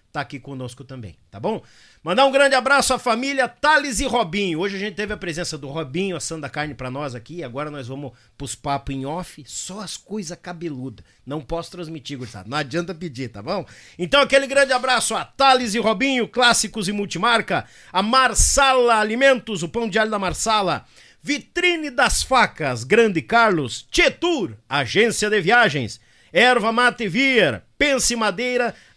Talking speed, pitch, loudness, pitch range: 170 wpm, 205 Hz, -19 LUFS, 150-245 Hz